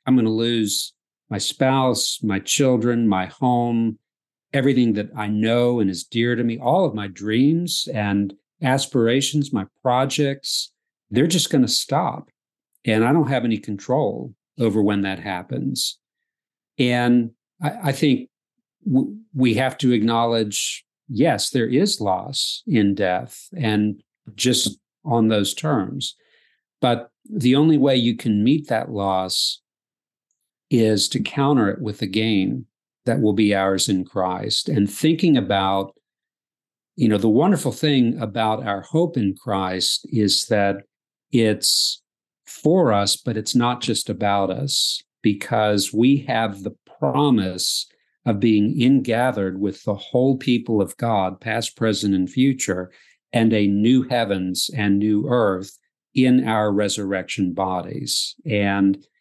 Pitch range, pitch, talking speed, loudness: 100-130 Hz, 110 Hz, 140 wpm, -20 LUFS